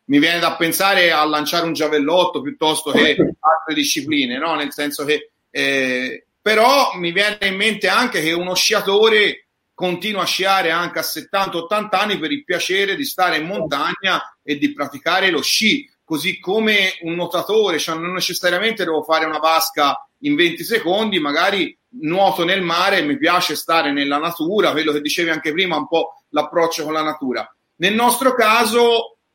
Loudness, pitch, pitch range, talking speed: -17 LUFS, 175 Hz, 155-215 Hz, 170 wpm